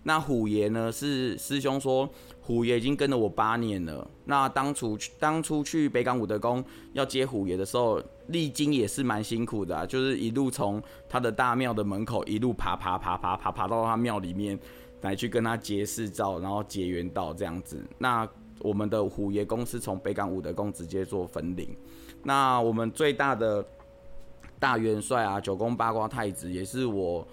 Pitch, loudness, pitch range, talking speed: 110 Hz, -29 LUFS, 100-125 Hz, 275 characters per minute